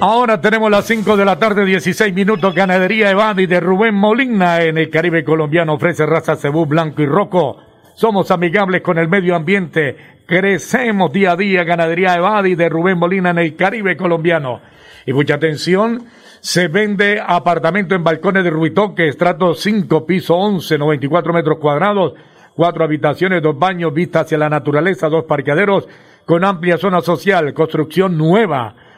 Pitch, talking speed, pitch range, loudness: 175 Hz, 160 wpm, 160-195 Hz, -14 LUFS